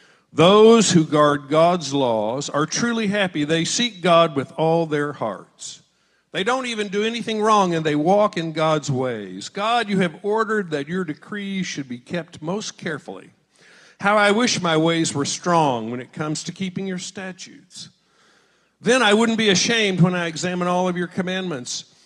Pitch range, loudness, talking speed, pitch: 155-205 Hz, -20 LUFS, 175 wpm, 180 Hz